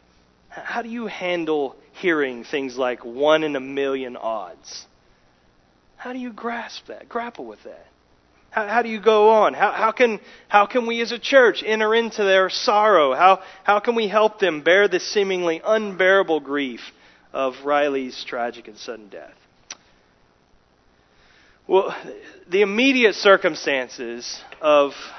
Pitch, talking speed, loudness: 175 Hz, 145 wpm, -20 LUFS